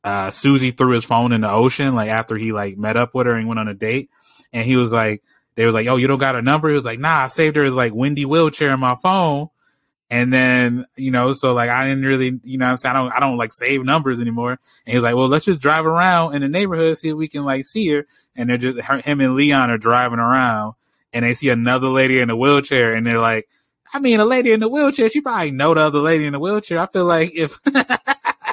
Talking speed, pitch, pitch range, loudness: 275 wpm, 130 Hz, 120-155 Hz, -17 LUFS